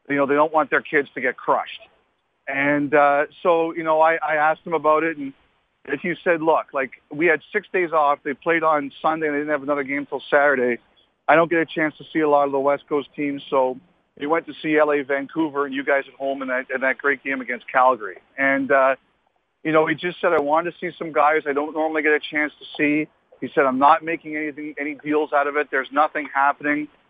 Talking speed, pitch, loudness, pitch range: 250 wpm, 150 Hz, -21 LUFS, 140-155 Hz